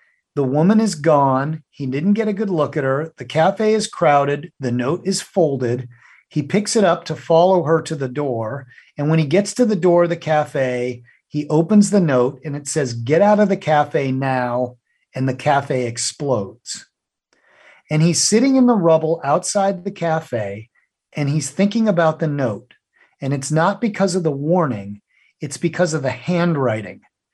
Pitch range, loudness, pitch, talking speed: 130-180 Hz, -18 LUFS, 155 Hz, 185 wpm